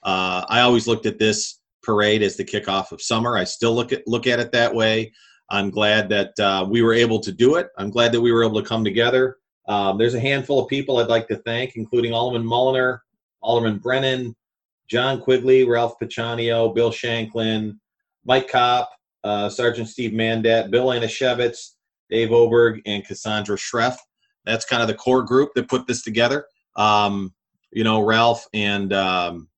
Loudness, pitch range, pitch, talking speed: -20 LUFS, 105-120 Hz, 115 Hz, 185 wpm